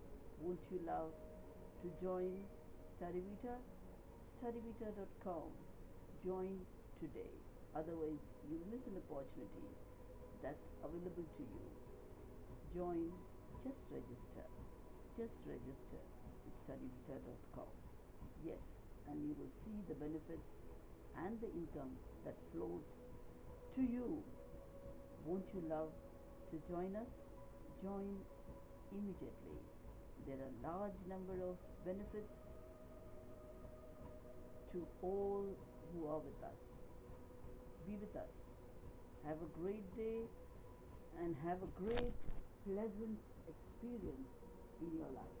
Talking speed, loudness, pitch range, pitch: 100 wpm, -51 LUFS, 155-200 Hz, 180 Hz